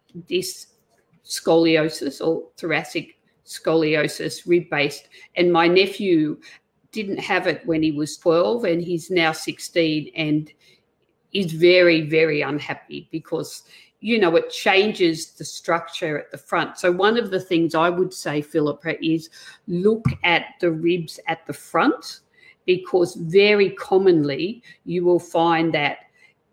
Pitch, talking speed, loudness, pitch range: 170 Hz, 135 wpm, -21 LUFS, 160-185 Hz